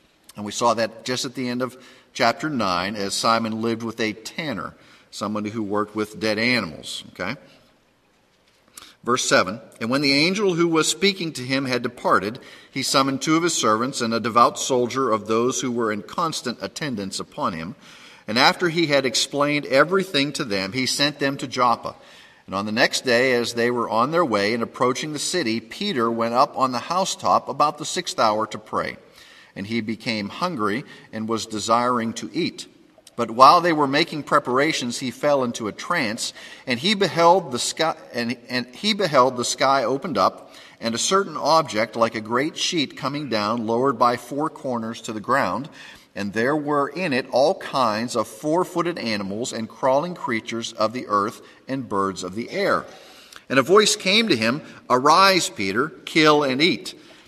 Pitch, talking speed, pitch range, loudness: 125 Hz, 185 wpm, 115-150 Hz, -21 LUFS